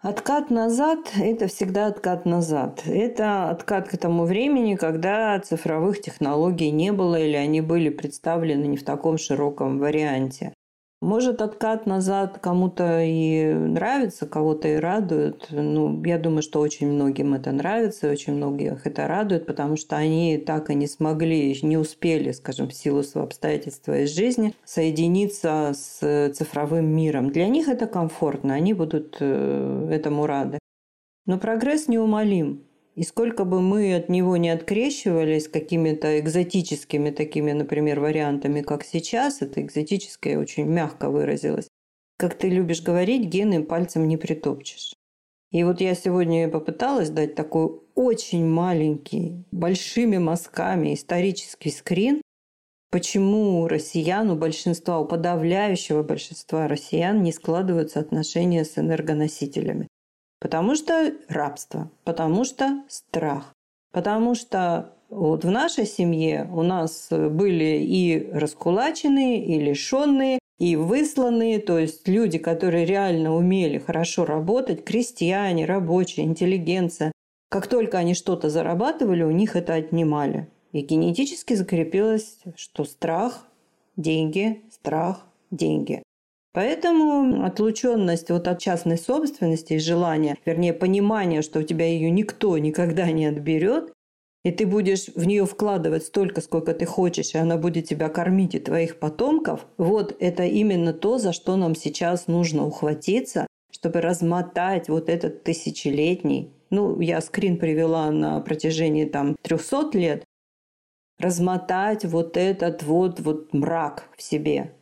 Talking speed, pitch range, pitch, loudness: 130 wpm, 155-195 Hz, 170 Hz, -23 LUFS